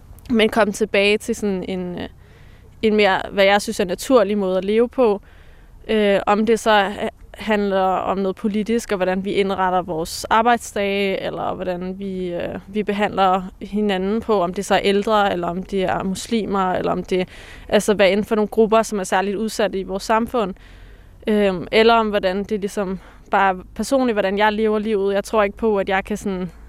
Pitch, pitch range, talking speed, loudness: 205 Hz, 190-215 Hz, 190 wpm, -19 LUFS